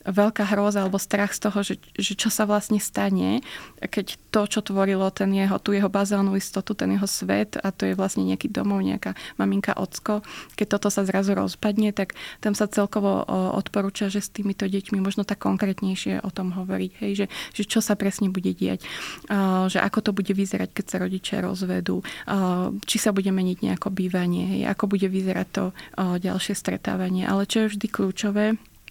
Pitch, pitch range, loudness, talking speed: 195 Hz, 185-205 Hz, -25 LUFS, 185 wpm